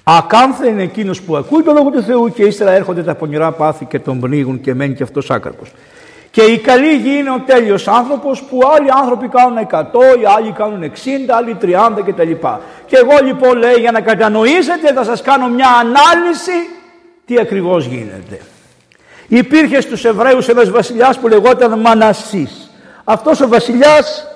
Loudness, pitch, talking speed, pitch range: -11 LUFS, 235 Hz, 170 wpm, 200-270 Hz